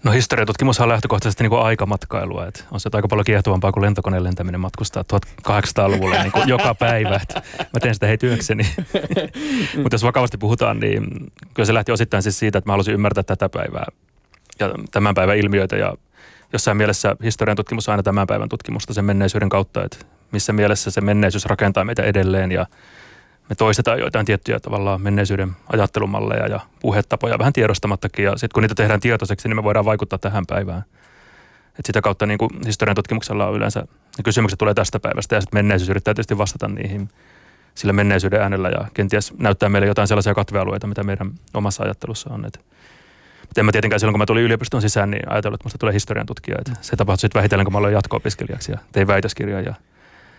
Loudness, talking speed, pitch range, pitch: -19 LUFS, 185 wpm, 100-115 Hz, 105 Hz